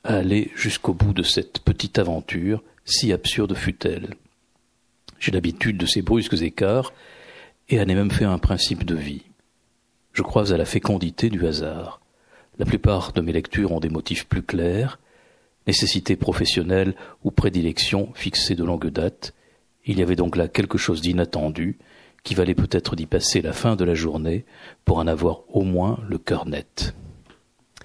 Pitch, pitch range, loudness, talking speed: 95 Hz, 85-105 Hz, -22 LUFS, 170 wpm